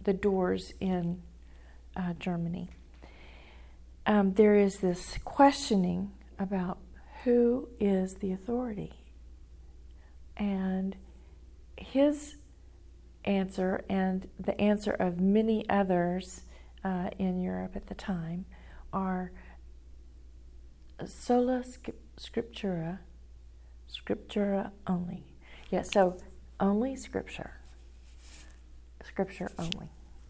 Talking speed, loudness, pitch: 85 wpm, -31 LUFS, 180 Hz